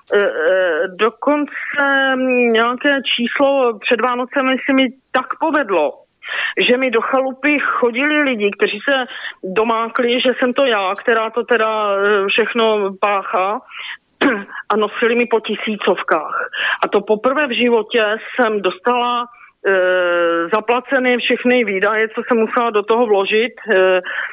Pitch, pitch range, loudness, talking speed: 240 Hz, 215-260 Hz, -16 LUFS, 125 wpm